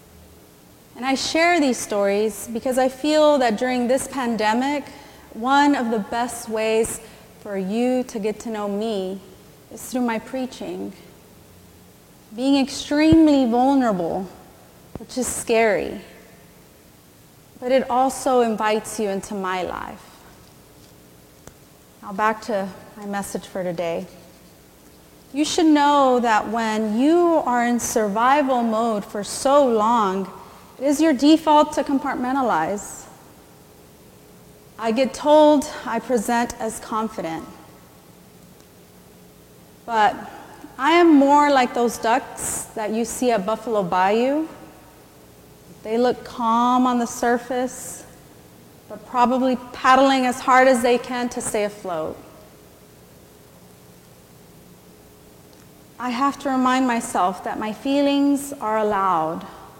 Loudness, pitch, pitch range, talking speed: -20 LUFS, 230 Hz, 195-260 Hz, 115 wpm